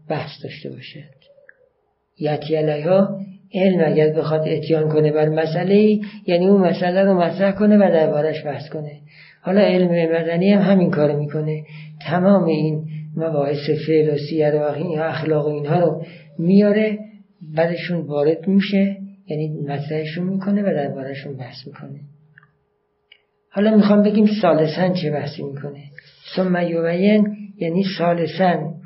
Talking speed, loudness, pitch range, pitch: 125 wpm, -18 LUFS, 155-195 Hz, 165 Hz